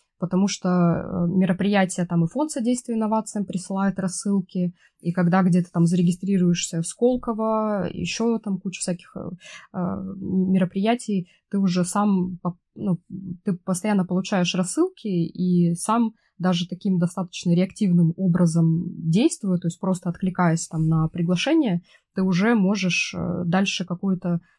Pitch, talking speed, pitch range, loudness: 185 Hz, 125 wpm, 175-200 Hz, -23 LUFS